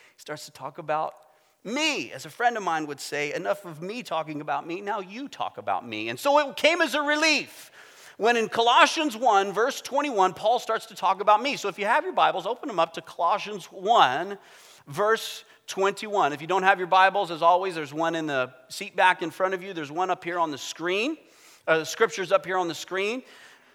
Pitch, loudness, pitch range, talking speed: 195 Hz, -25 LUFS, 165-230 Hz, 225 wpm